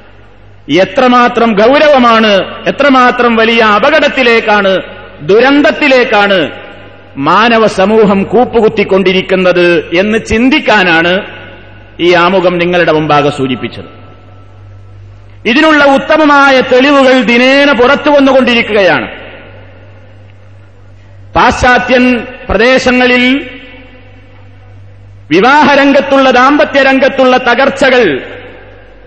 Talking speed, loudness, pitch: 55 wpm, -7 LUFS, 215 Hz